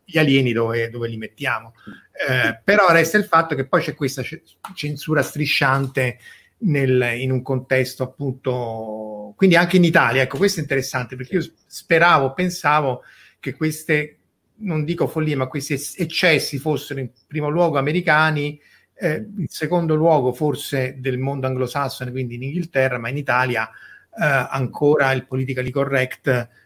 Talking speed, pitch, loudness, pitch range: 150 wpm, 140 Hz, -20 LUFS, 130-155 Hz